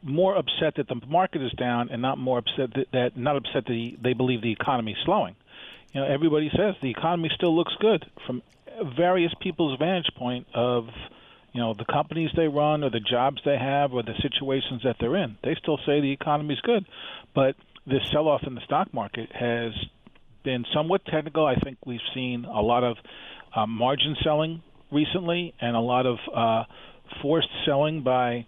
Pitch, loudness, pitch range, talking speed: 135 Hz, -26 LUFS, 120-155 Hz, 195 wpm